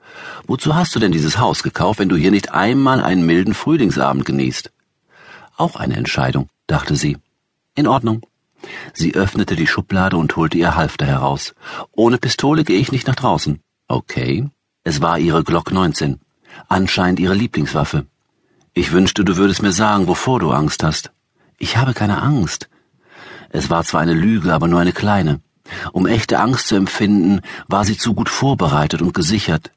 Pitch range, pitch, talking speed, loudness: 85-120 Hz, 100 Hz, 165 wpm, -16 LUFS